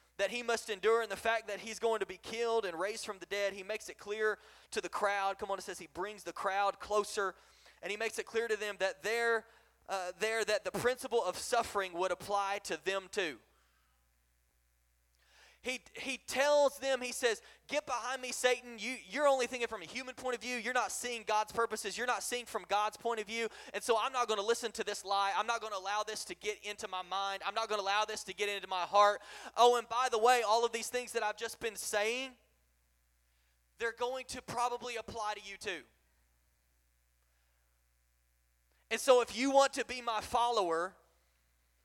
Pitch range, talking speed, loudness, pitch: 190-235 Hz, 215 wpm, -35 LUFS, 215 Hz